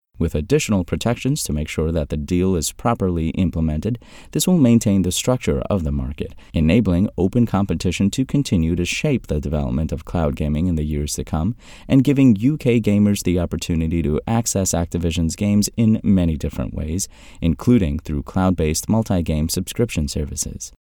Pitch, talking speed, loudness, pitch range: 90 Hz, 165 wpm, -20 LUFS, 80-105 Hz